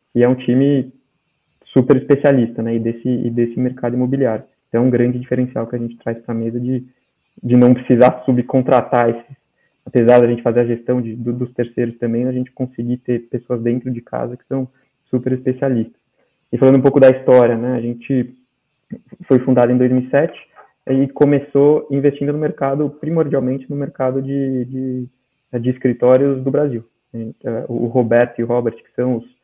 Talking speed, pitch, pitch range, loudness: 180 wpm, 125 Hz, 120-135 Hz, -16 LUFS